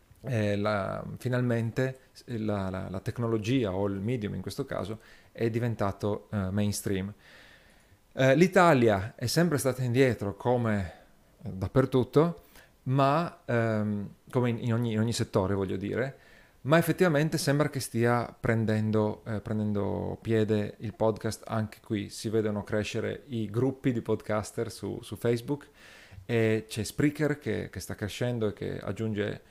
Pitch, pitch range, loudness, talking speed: 110 Hz, 105-125 Hz, -29 LUFS, 140 wpm